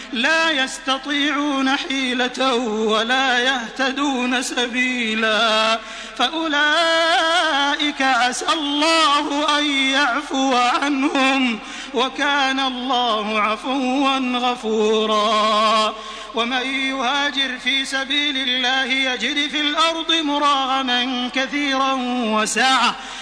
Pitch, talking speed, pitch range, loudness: 265 Hz, 70 wpm, 245-285 Hz, -18 LUFS